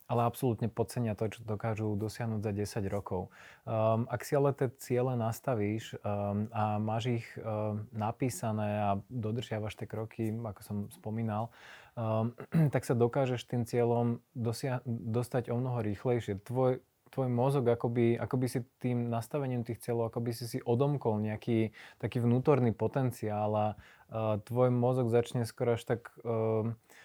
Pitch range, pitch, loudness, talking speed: 110-125 Hz, 115 Hz, -33 LUFS, 150 wpm